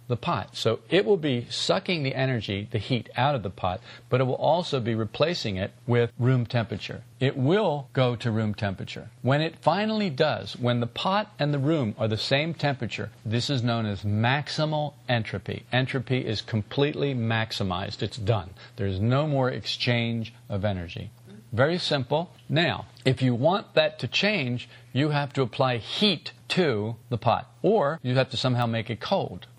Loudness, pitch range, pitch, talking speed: -26 LUFS, 115-140 Hz, 125 Hz, 180 wpm